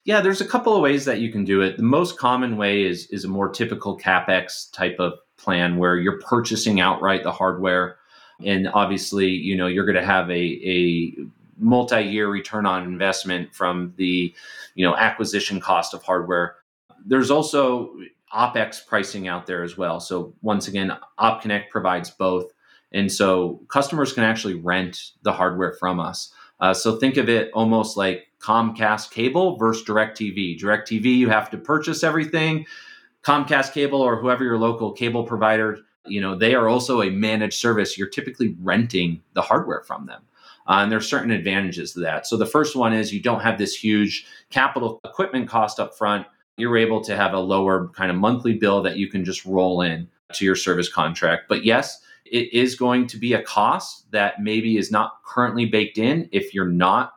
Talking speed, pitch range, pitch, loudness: 185 wpm, 95-115 Hz, 105 Hz, -21 LUFS